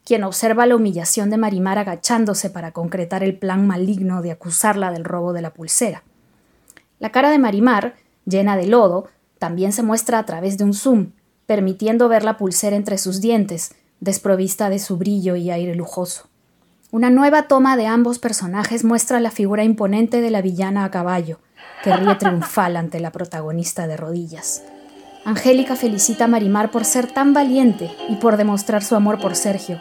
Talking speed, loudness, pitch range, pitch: 175 wpm, -18 LUFS, 180-225 Hz, 200 Hz